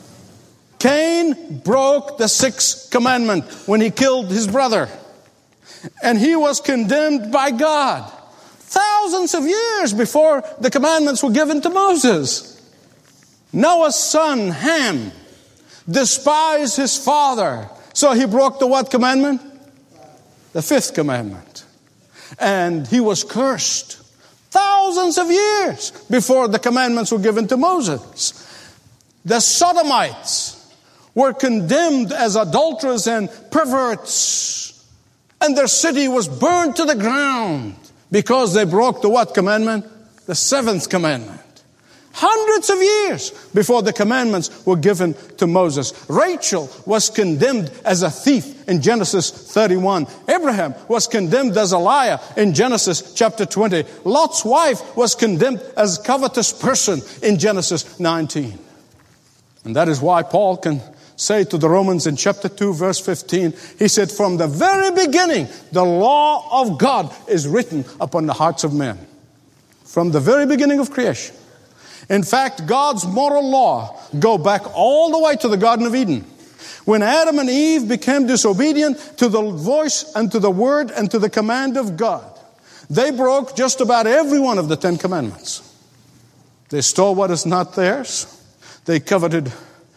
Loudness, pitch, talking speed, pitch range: -17 LUFS, 230 Hz, 140 wpm, 185-280 Hz